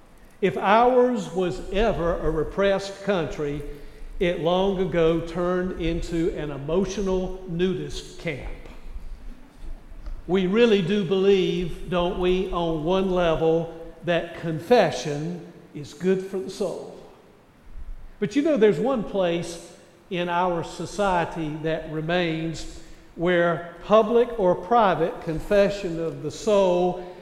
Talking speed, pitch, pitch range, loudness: 110 wpm, 180 Hz, 165-195 Hz, -24 LUFS